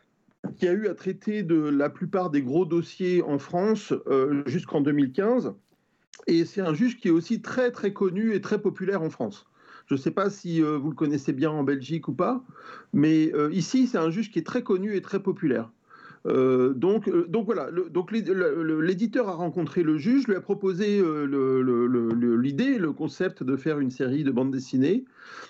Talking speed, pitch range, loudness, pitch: 205 wpm, 150-200 Hz, -26 LUFS, 175 Hz